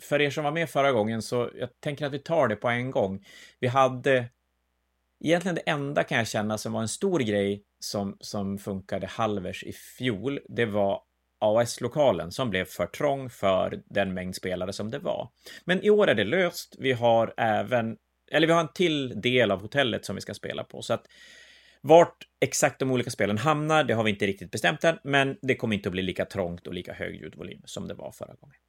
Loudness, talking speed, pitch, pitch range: -26 LUFS, 220 wpm, 120 Hz, 100-145 Hz